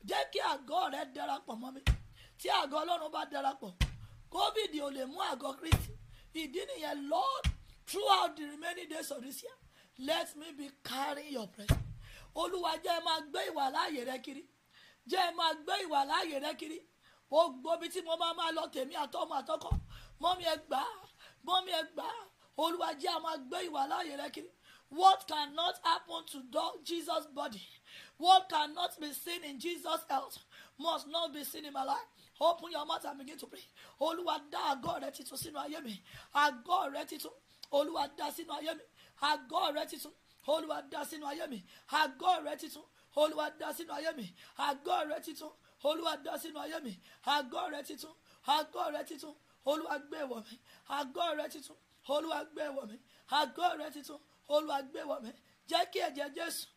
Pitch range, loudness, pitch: 285-335 Hz, -36 LUFS, 310 Hz